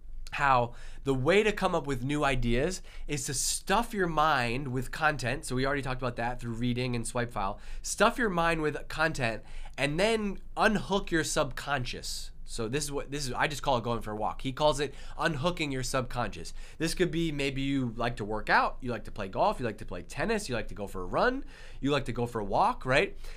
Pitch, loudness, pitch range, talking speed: 140 Hz, -30 LUFS, 120-160 Hz, 235 wpm